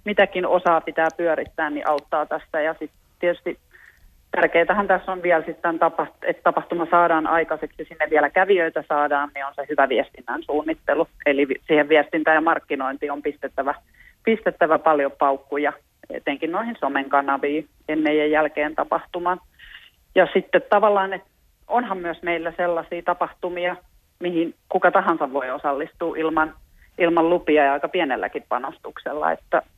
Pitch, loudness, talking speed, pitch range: 160 Hz, -22 LUFS, 135 wpm, 150-175 Hz